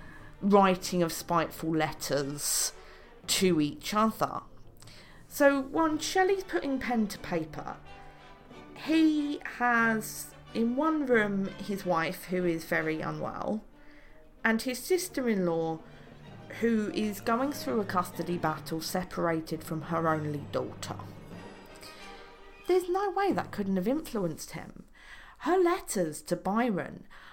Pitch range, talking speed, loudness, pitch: 165-260 Hz, 115 wpm, -30 LUFS, 195 Hz